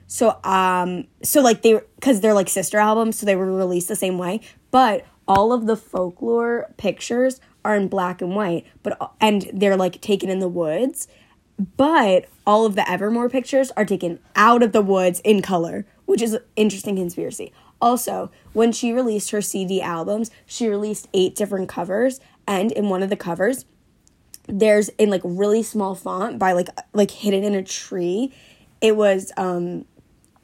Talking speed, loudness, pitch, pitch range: 175 wpm, -20 LUFS, 205 Hz, 190-225 Hz